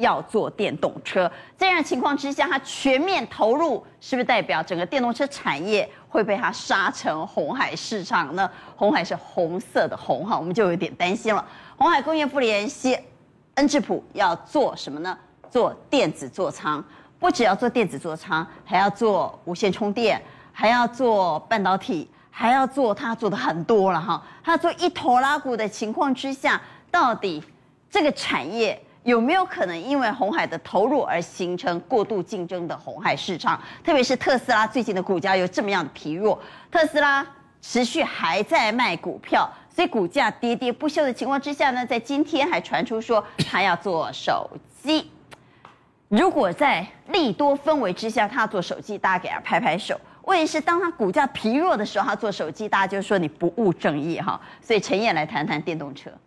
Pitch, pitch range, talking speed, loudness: 240 Hz, 195-290 Hz, 275 characters per minute, -23 LUFS